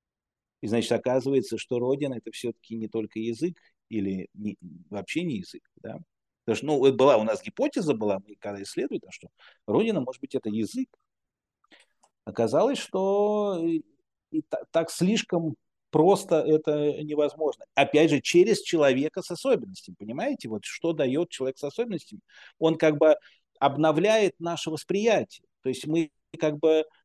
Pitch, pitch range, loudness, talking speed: 155 Hz, 120-175 Hz, -26 LUFS, 155 wpm